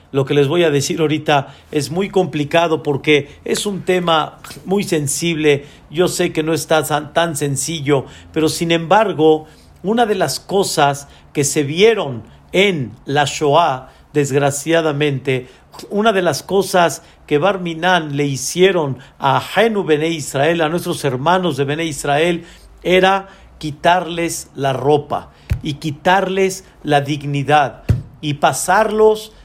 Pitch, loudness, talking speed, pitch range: 155 Hz, -16 LUFS, 130 wpm, 145-180 Hz